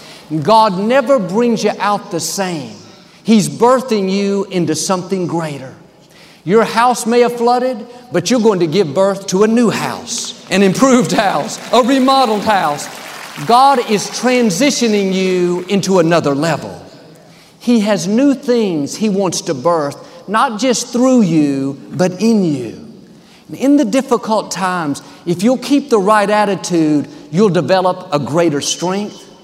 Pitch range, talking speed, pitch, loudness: 175-235 Hz, 145 wpm, 200 Hz, -14 LUFS